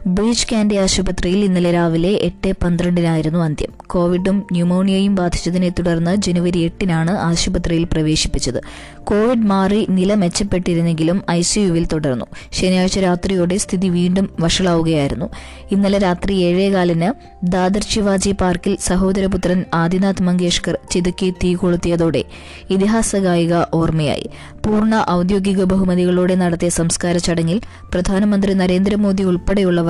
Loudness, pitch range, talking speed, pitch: -17 LUFS, 175-195 Hz, 100 wpm, 180 Hz